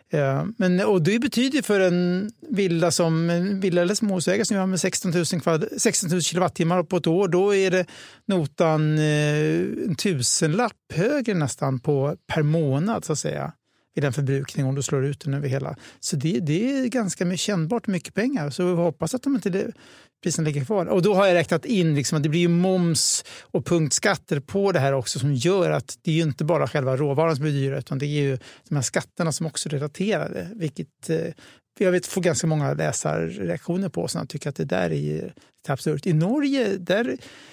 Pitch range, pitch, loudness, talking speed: 150-190 Hz, 170 Hz, -23 LUFS, 210 wpm